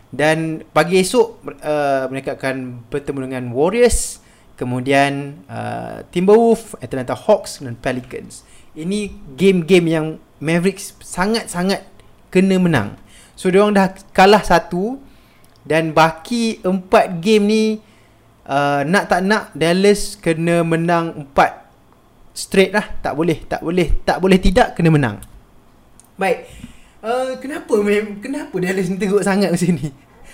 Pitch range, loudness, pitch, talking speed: 145-205 Hz, -17 LUFS, 175 Hz, 125 wpm